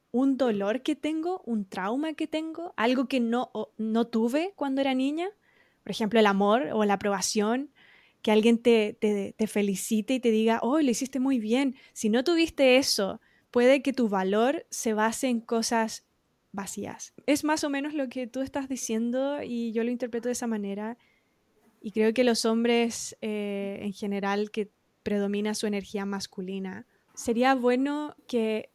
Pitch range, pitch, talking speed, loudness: 215-265 Hz, 235 Hz, 175 wpm, -27 LUFS